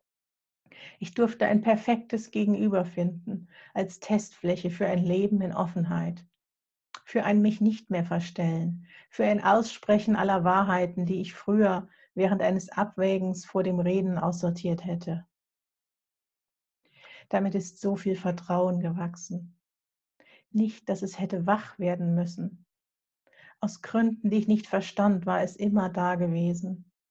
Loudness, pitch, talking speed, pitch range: -28 LUFS, 190 Hz, 130 wpm, 180-205 Hz